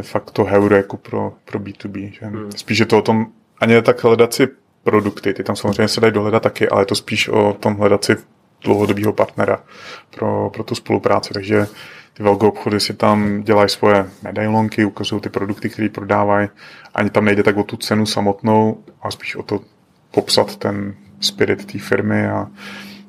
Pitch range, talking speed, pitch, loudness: 100-110 Hz, 185 wpm, 105 Hz, -17 LUFS